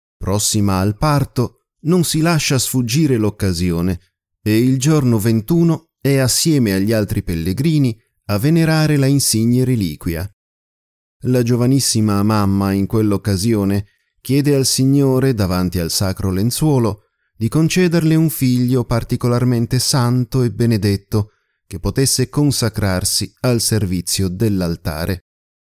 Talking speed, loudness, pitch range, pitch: 110 wpm, -16 LUFS, 100-135 Hz, 115 Hz